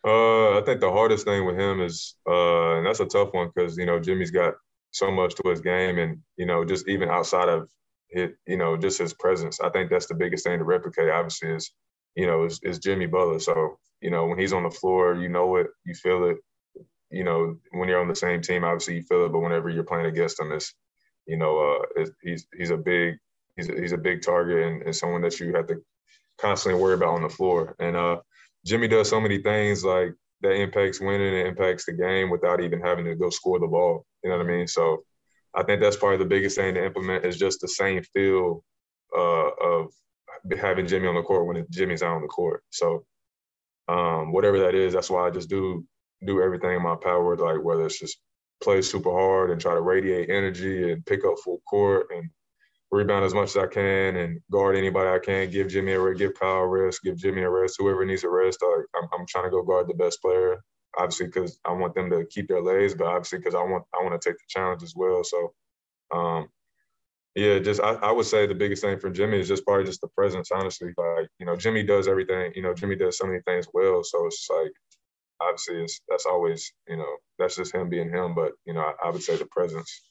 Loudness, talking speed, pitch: -25 LUFS, 240 wpm, 95 Hz